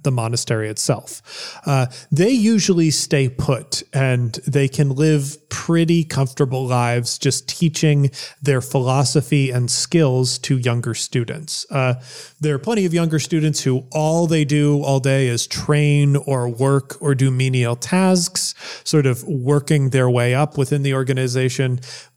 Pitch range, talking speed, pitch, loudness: 130-150 Hz, 145 wpm, 140 Hz, -18 LUFS